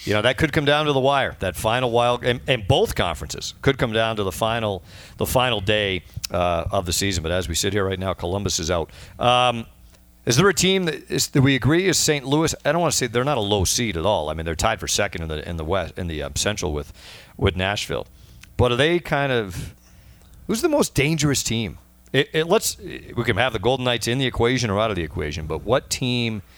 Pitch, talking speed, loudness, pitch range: 110 Hz, 255 wpm, -21 LUFS, 90-135 Hz